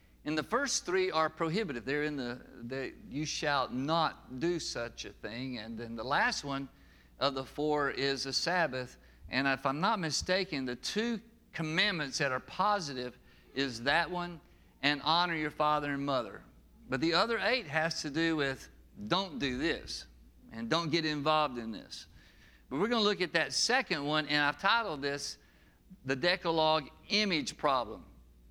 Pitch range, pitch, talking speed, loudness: 130-170 Hz, 150 Hz, 175 wpm, -32 LUFS